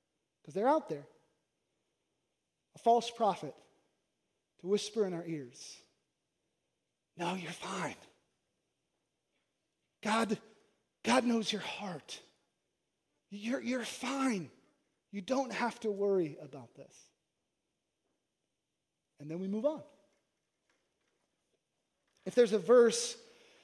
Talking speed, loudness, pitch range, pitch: 100 wpm, -34 LUFS, 185-250 Hz, 215 Hz